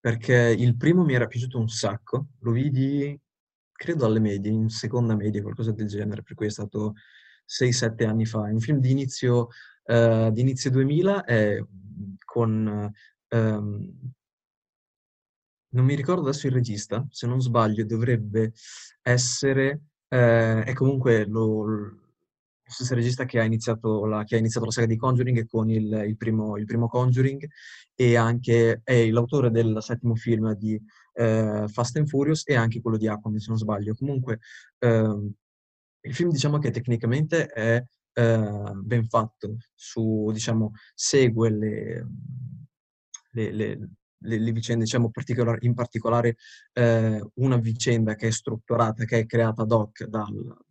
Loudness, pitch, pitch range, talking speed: -24 LUFS, 115 Hz, 110-125 Hz, 150 wpm